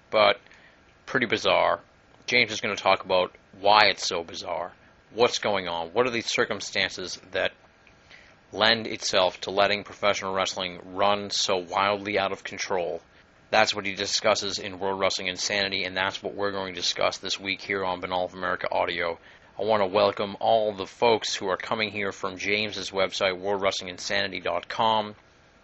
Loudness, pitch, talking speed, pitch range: -25 LUFS, 95 Hz, 165 wpm, 90-100 Hz